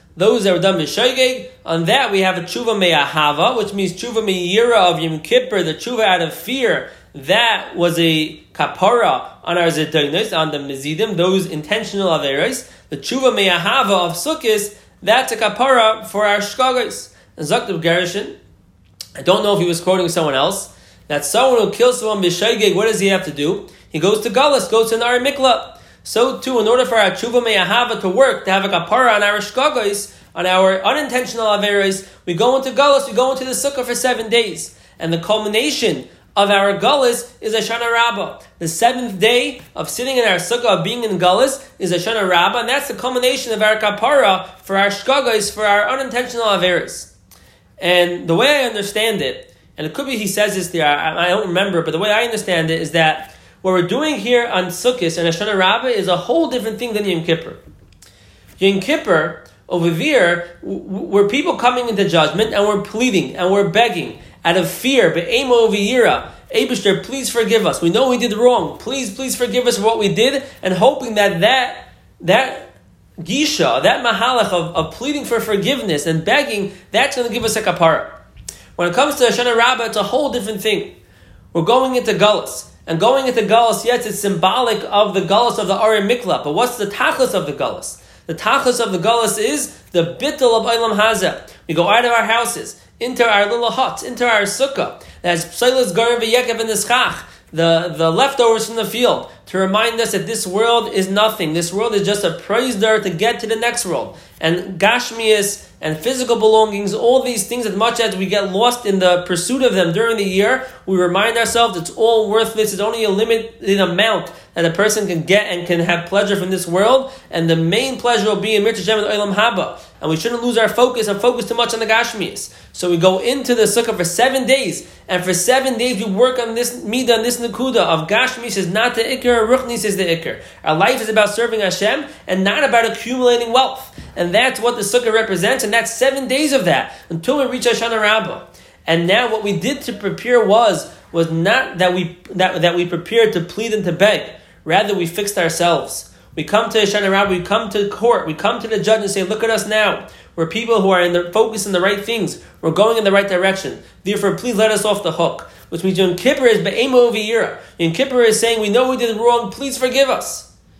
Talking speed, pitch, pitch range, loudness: 210 wpm, 215 Hz, 185-240 Hz, -16 LUFS